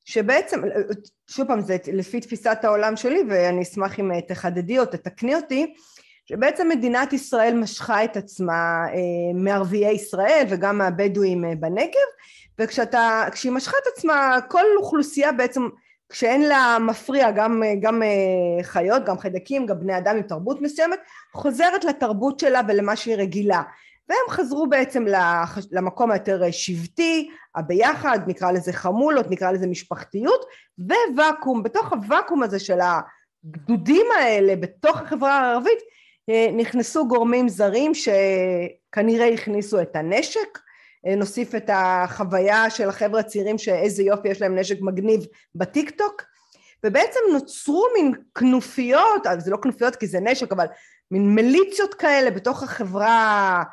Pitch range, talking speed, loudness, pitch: 195-275 Hz, 125 wpm, -21 LUFS, 225 Hz